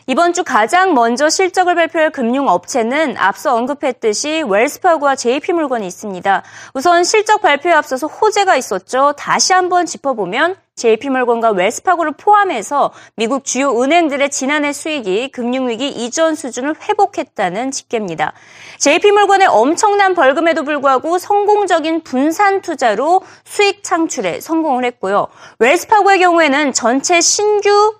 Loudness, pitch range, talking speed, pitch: -14 LUFS, 260-365 Hz, 340 characters per minute, 315 Hz